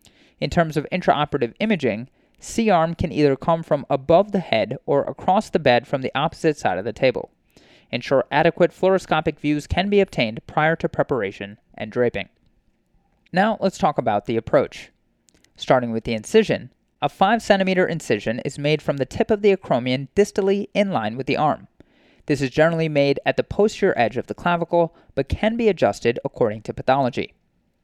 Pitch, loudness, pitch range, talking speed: 160 Hz, -21 LUFS, 135-195 Hz, 180 wpm